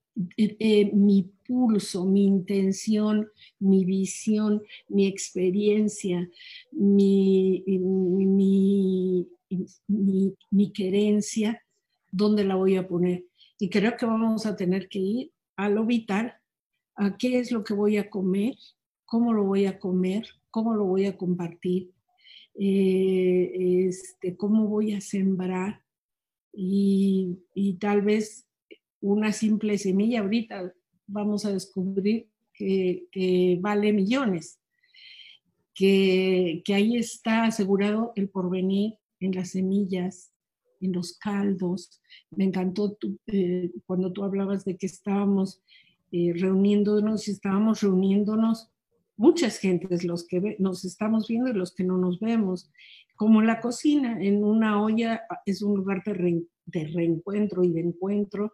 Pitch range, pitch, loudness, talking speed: 185-215 Hz, 195 Hz, -25 LUFS, 130 wpm